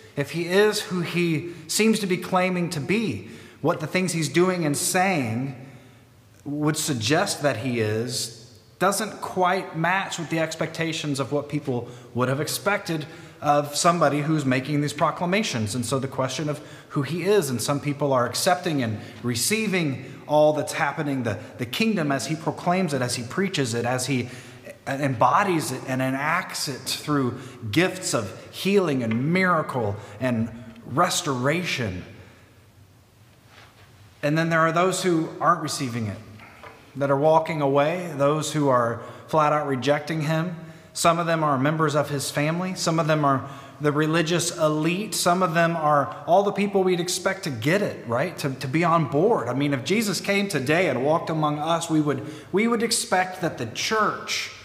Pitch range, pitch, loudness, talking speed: 130-170 Hz, 150 Hz, -24 LUFS, 170 wpm